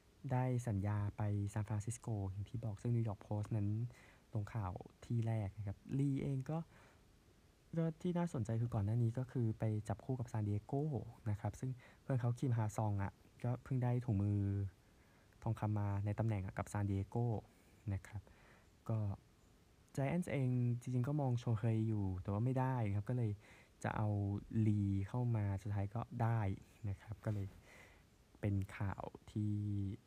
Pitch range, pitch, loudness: 100-120 Hz, 110 Hz, -41 LUFS